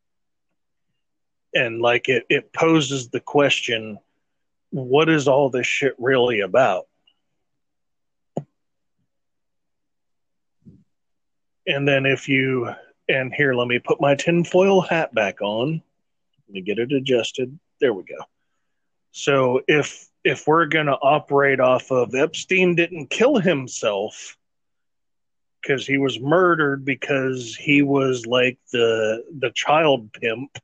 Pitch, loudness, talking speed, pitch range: 135 Hz, -20 LUFS, 120 wpm, 125-150 Hz